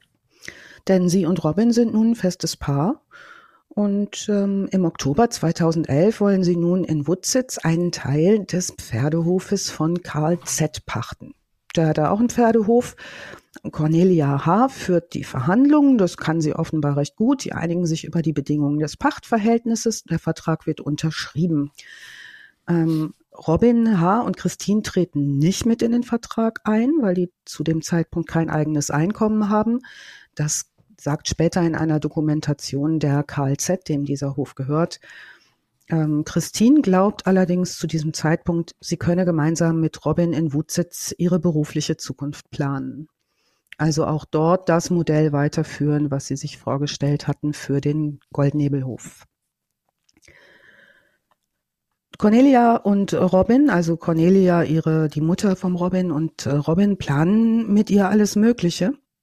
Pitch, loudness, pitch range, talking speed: 170 Hz, -20 LUFS, 150-200 Hz, 140 wpm